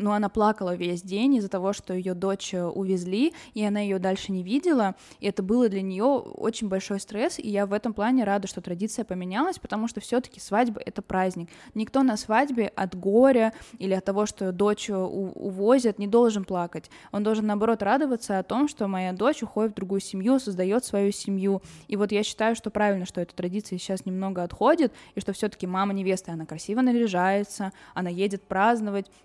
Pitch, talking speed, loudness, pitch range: 205 Hz, 190 wpm, -26 LUFS, 190-225 Hz